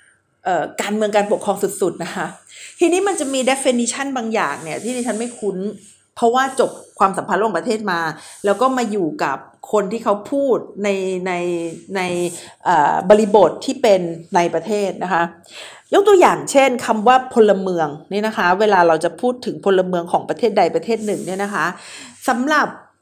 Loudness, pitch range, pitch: -18 LUFS, 180-245 Hz, 205 Hz